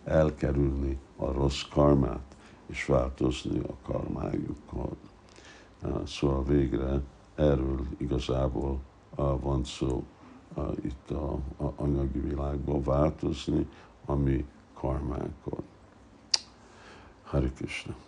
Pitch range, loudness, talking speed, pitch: 70-75 Hz, -31 LUFS, 75 wpm, 70 Hz